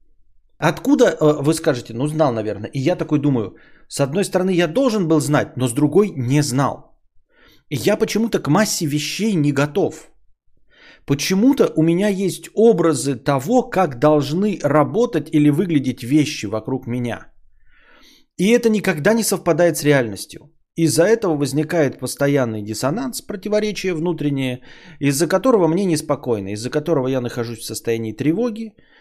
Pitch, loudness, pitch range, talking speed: 150 Hz, -18 LUFS, 135-185 Hz, 145 wpm